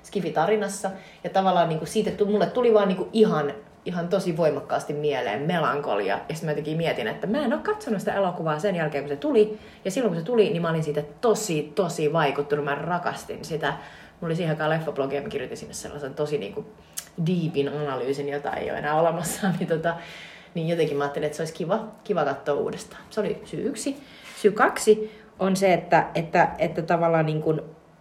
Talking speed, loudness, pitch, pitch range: 195 wpm, -25 LUFS, 170 Hz, 155-210 Hz